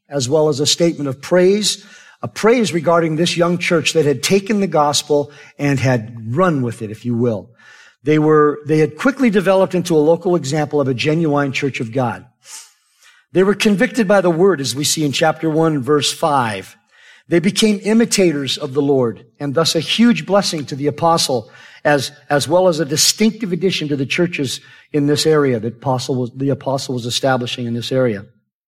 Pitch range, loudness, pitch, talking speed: 135-175 Hz, -16 LUFS, 150 Hz, 195 wpm